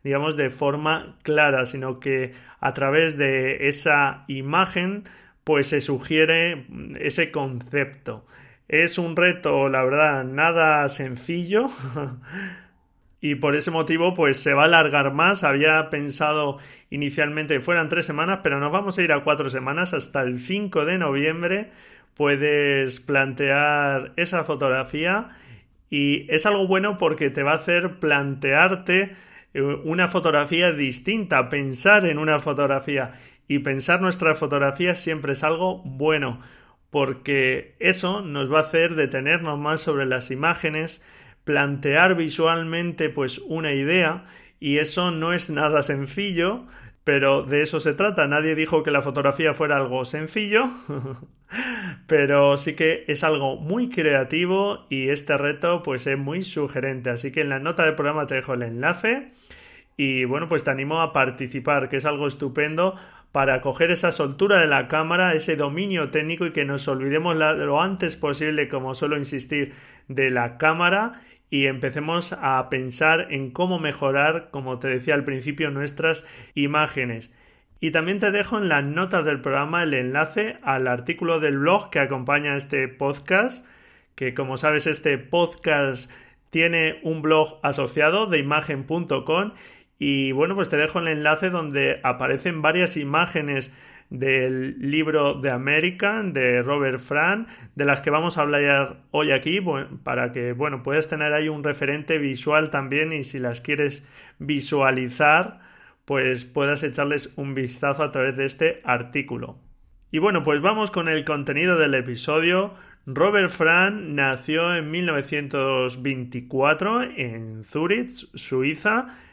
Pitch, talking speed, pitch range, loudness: 150 Hz, 145 wpm, 140-165 Hz, -22 LUFS